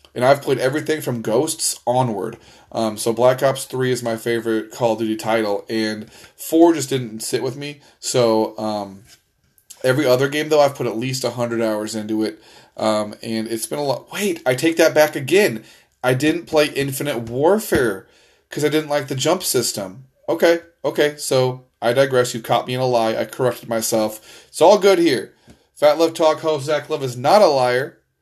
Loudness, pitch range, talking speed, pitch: -19 LUFS, 115-150 Hz, 195 wpm, 130 Hz